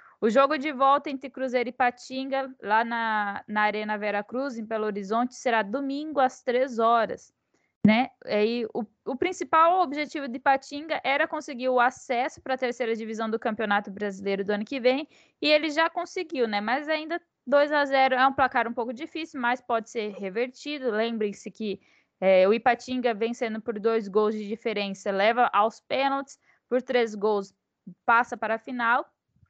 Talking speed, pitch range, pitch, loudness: 175 wpm, 220-275 Hz, 245 Hz, -26 LUFS